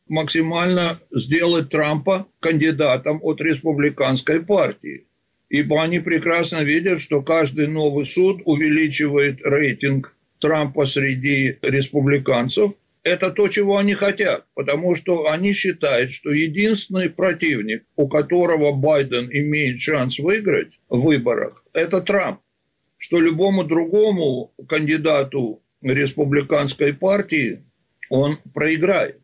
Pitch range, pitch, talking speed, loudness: 145-175 Hz, 155 Hz, 105 wpm, -19 LUFS